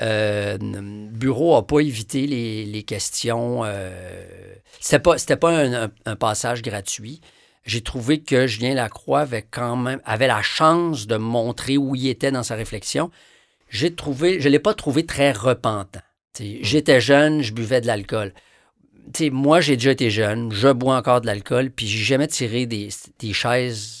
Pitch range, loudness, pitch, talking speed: 110-140 Hz, -20 LUFS, 125 Hz, 180 wpm